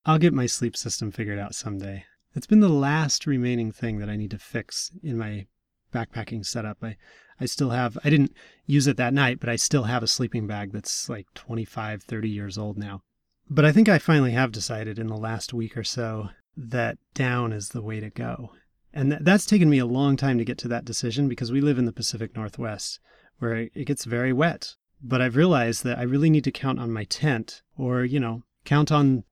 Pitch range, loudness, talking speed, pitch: 110-140 Hz, -25 LUFS, 225 wpm, 120 Hz